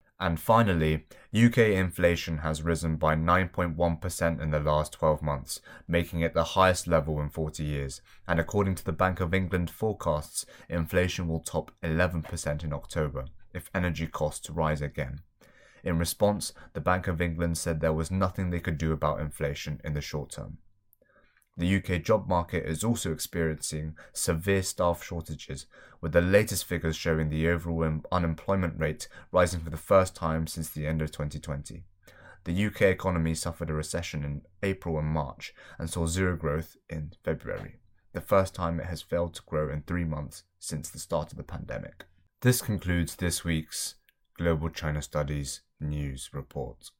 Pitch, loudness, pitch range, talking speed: 85 Hz, -29 LUFS, 75-90 Hz, 165 wpm